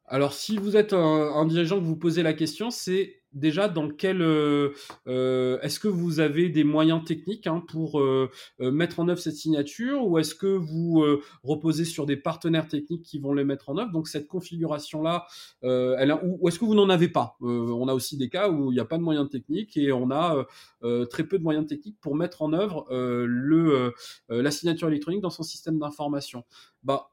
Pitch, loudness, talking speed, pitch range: 155 Hz, -26 LUFS, 220 wpm, 140-170 Hz